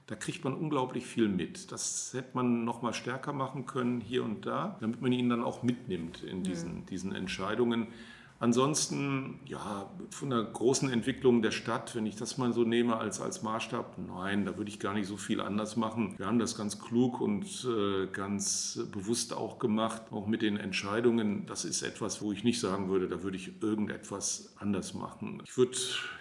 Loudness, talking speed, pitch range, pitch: -33 LUFS, 190 wpm, 105-125 Hz, 115 Hz